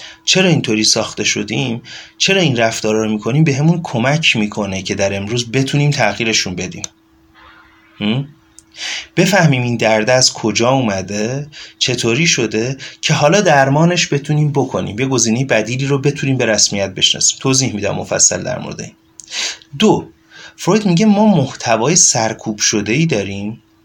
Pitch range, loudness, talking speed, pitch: 110-150 Hz, -14 LUFS, 140 wpm, 130 Hz